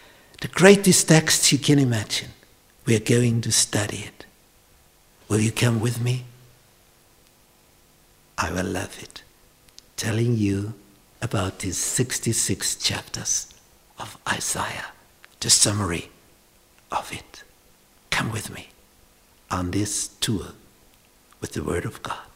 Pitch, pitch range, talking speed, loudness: 115 Hz, 100-125 Hz, 120 wpm, -22 LUFS